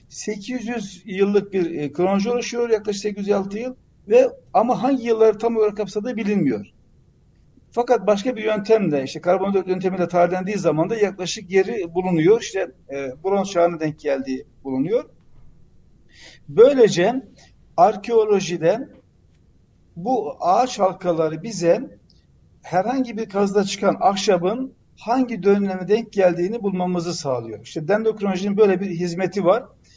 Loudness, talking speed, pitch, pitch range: -21 LUFS, 120 wpm, 200 Hz, 175-220 Hz